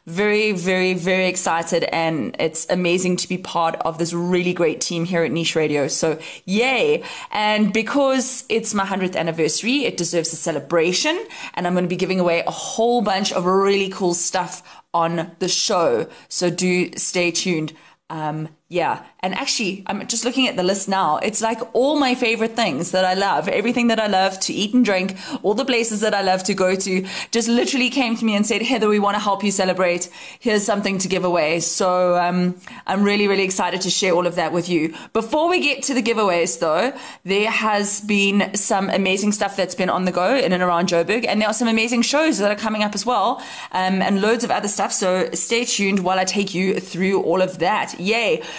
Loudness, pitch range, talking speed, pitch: -19 LUFS, 180-225 Hz, 215 wpm, 190 Hz